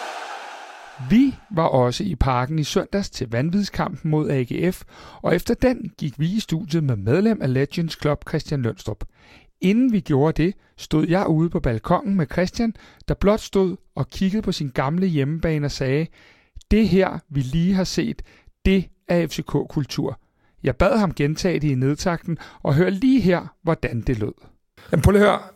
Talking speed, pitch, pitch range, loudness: 170 wpm, 165 Hz, 140-190 Hz, -22 LUFS